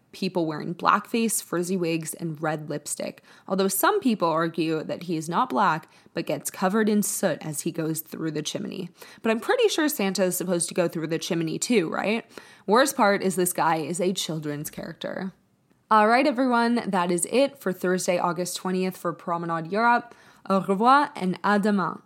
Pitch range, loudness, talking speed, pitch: 170-215 Hz, -25 LUFS, 190 wpm, 185 Hz